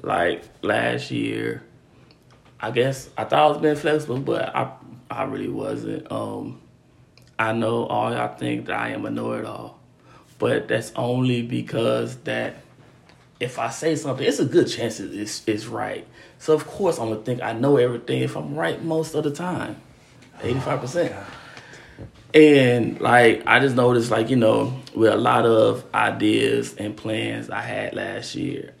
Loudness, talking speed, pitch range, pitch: -22 LUFS, 165 wpm, 110-150 Hz, 125 Hz